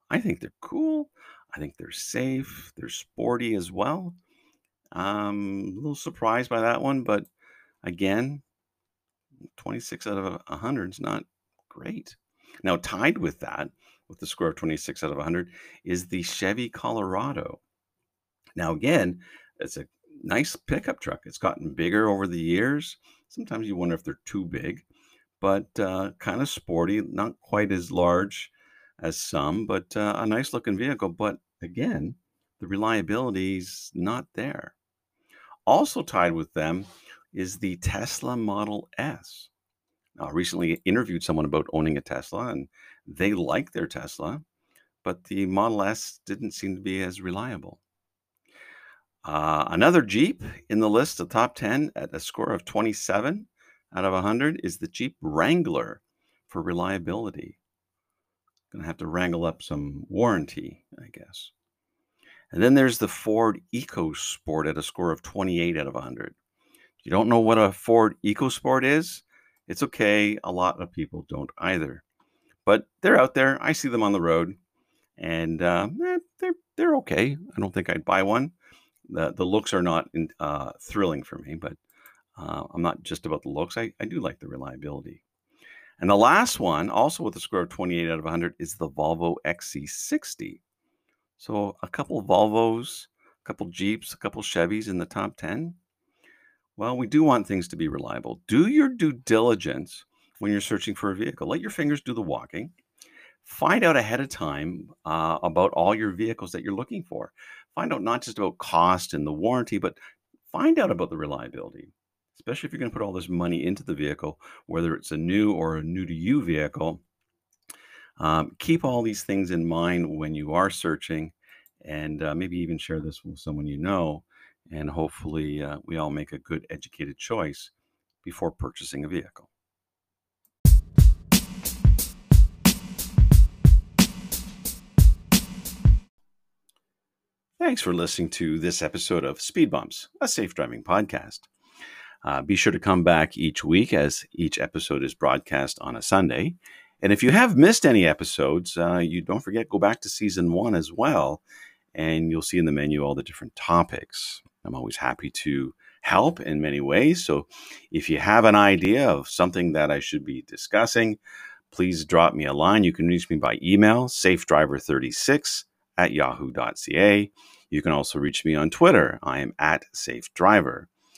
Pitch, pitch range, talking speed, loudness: 95 Hz, 85-115 Hz, 170 wpm, -25 LUFS